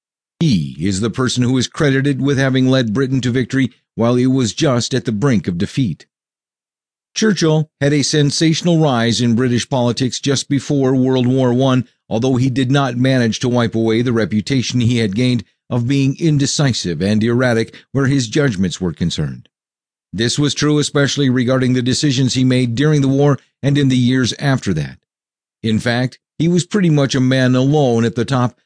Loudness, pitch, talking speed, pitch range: -16 LUFS, 130 Hz, 185 wpm, 120-140 Hz